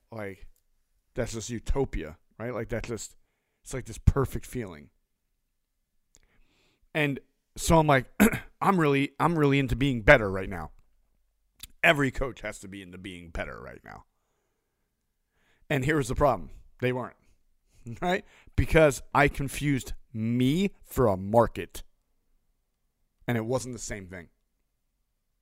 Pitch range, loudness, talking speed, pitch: 100-140 Hz, -27 LUFS, 130 wpm, 125 Hz